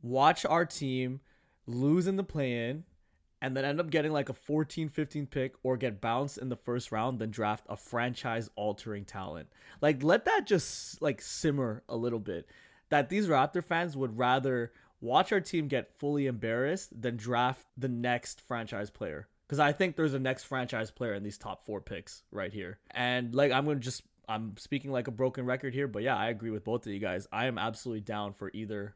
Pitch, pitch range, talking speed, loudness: 125 Hz, 110-140 Hz, 205 wpm, -32 LUFS